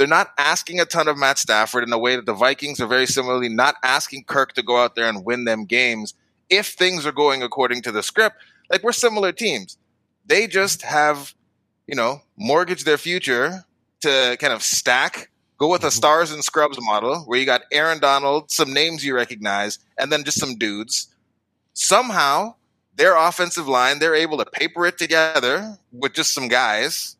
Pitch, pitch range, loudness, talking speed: 140 Hz, 120-160 Hz, -19 LUFS, 190 wpm